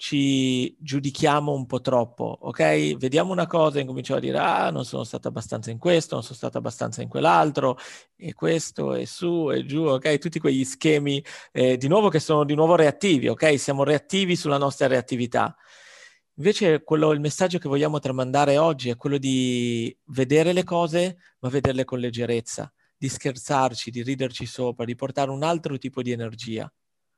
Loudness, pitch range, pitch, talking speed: -23 LUFS, 125-155 Hz, 140 Hz, 175 wpm